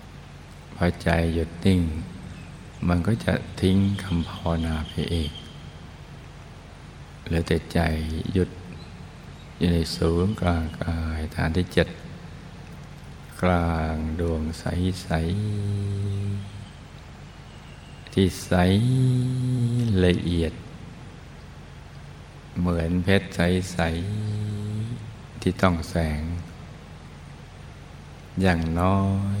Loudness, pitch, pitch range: -25 LUFS, 85 Hz, 80-95 Hz